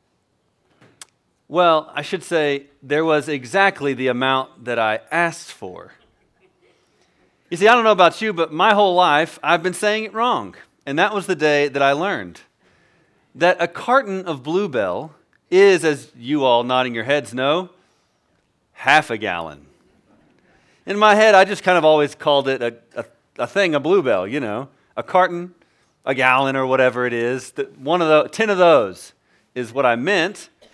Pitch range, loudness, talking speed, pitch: 135-190 Hz, -18 LUFS, 170 wpm, 155 Hz